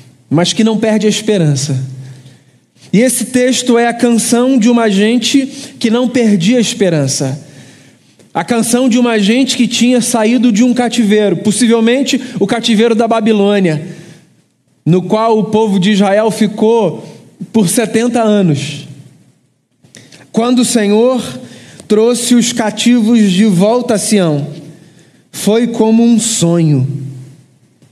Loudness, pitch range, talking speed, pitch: -11 LUFS, 160-235 Hz, 130 wpm, 215 Hz